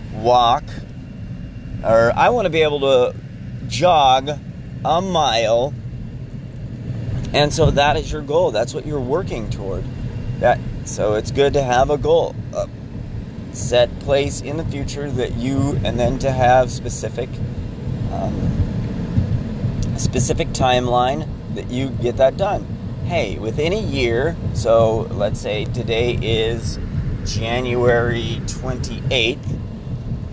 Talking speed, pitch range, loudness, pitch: 125 wpm, 115-130 Hz, -19 LUFS, 120 Hz